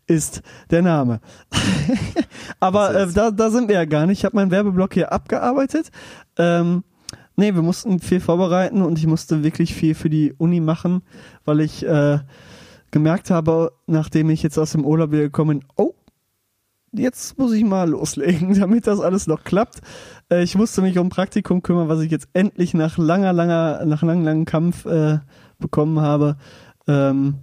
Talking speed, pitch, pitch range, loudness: 175 wpm, 170 Hz, 155-190 Hz, -19 LUFS